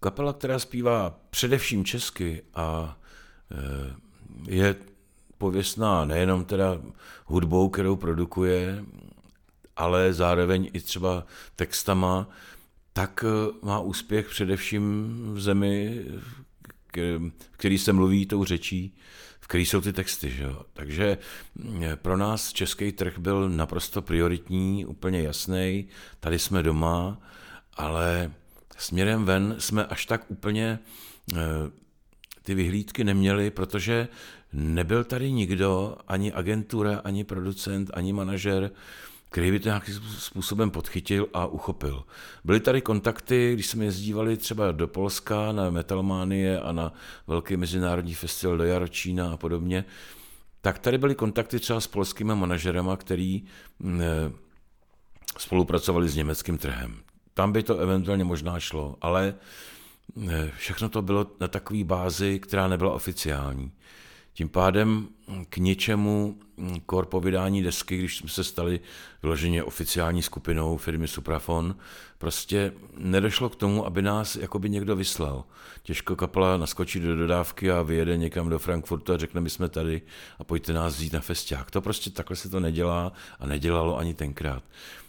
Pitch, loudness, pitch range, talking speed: 95 Hz, -27 LUFS, 85-100 Hz, 130 wpm